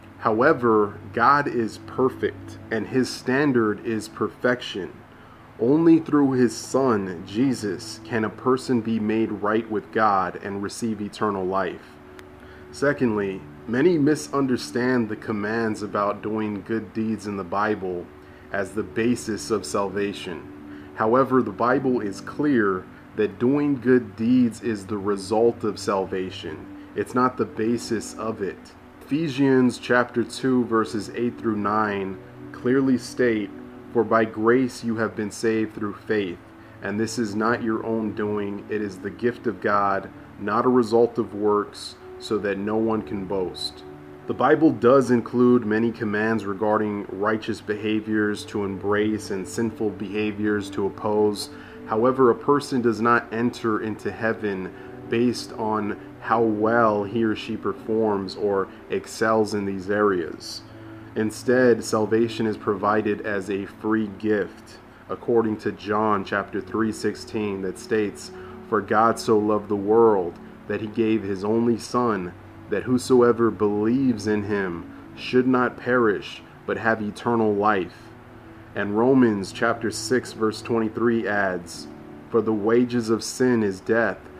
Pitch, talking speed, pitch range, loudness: 110 Hz, 140 wpm, 105-120 Hz, -23 LUFS